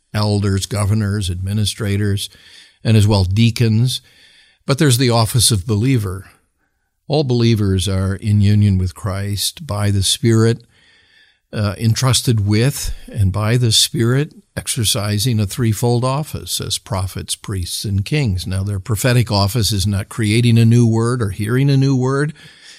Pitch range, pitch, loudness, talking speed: 100-120 Hz, 110 Hz, -17 LUFS, 140 wpm